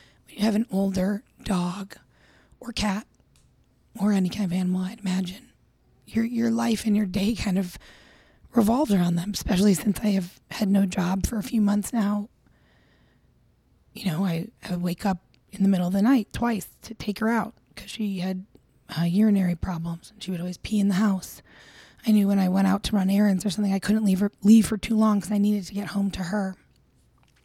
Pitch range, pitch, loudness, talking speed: 185-215 Hz, 200 Hz, -25 LUFS, 210 wpm